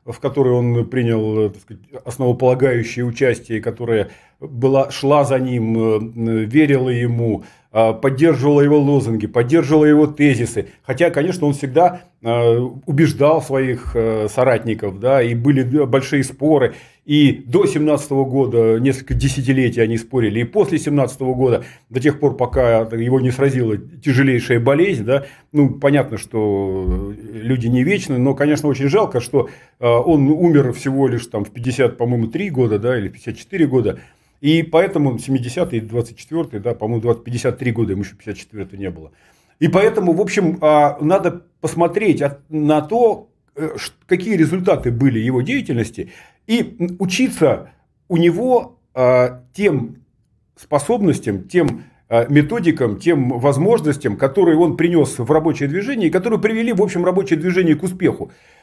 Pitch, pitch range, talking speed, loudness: 135 Hz, 120-155 Hz, 135 wpm, -17 LUFS